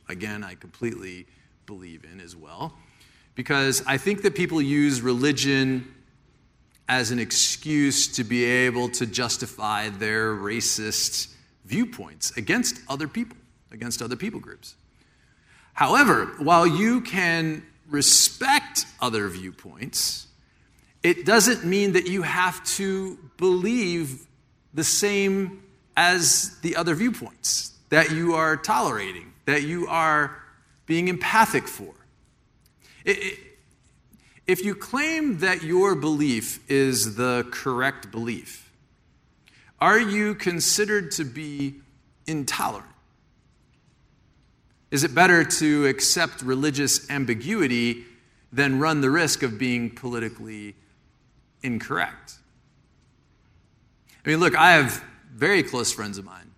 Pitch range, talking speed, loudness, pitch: 120-175 Hz, 110 wpm, -22 LUFS, 140 Hz